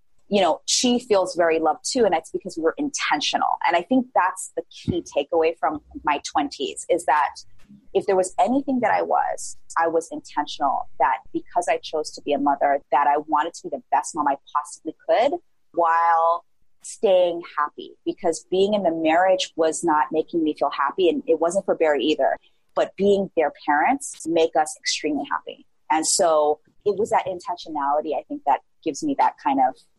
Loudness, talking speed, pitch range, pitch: -22 LUFS, 190 wpm, 155-245 Hz, 170 Hz